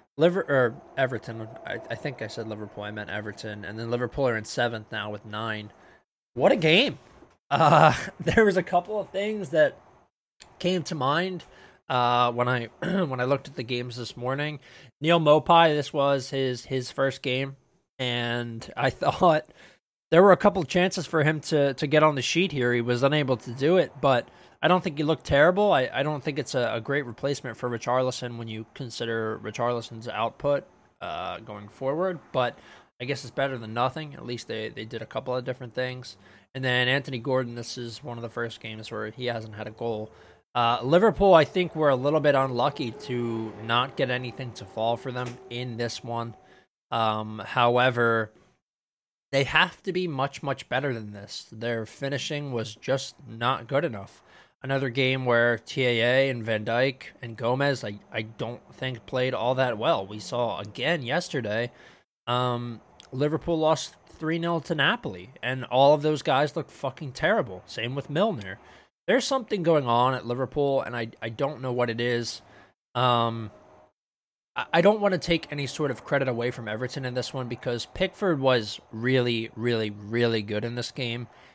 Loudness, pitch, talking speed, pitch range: -26 LUFS, 125 Hz, 190 wpm, 115-145 Hz